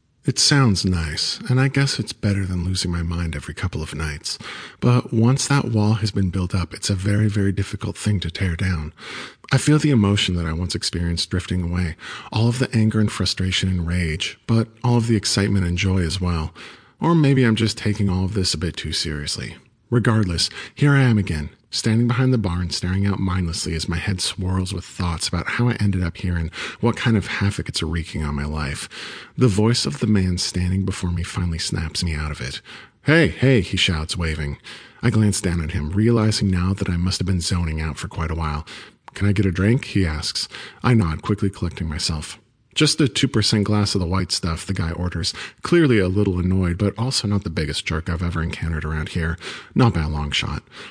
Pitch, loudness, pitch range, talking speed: 95 Hz, -21 LUFS, 85-110 Hz, 220 wpm